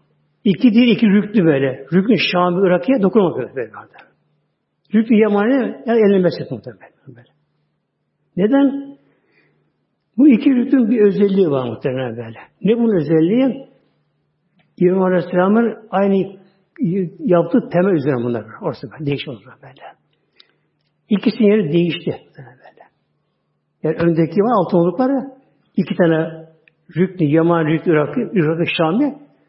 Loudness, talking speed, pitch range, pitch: -16 LUFS, 120 wpm, 160-220 Hz, 185 Hz